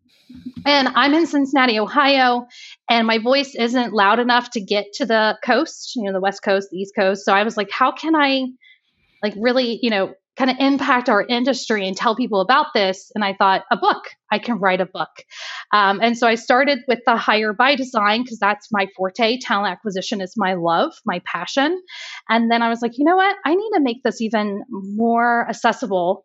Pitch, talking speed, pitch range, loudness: 235 Hz, 210 wpm, 205-260 Hz, -18 LUFS